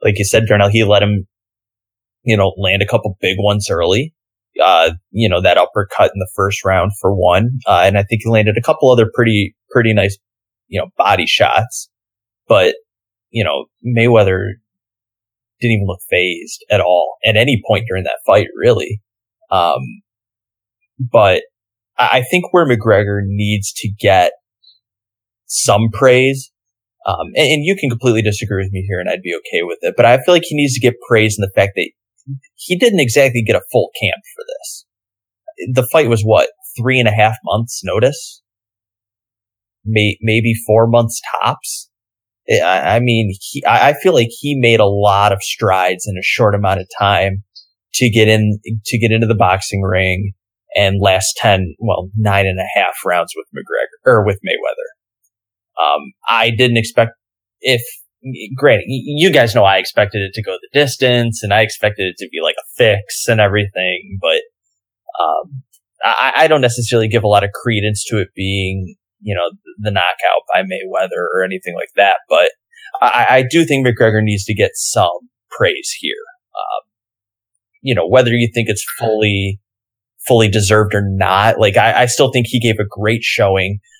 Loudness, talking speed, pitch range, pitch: -14 LUFS, 180 wpm, 100-120 Hz, 110 Hz